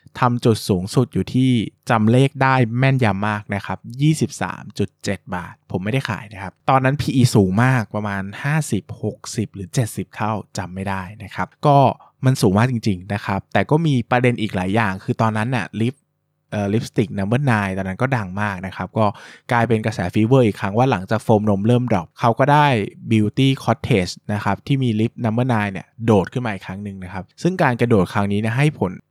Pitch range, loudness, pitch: 100-125 Hz, -19 LUFS, 110 Hz